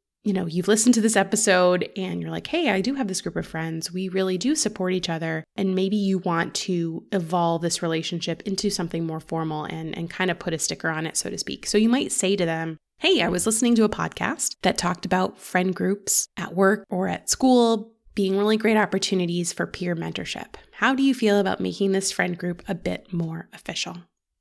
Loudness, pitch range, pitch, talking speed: -24 LUFS, 170-210 Hz, 185 Hz, 225 wpm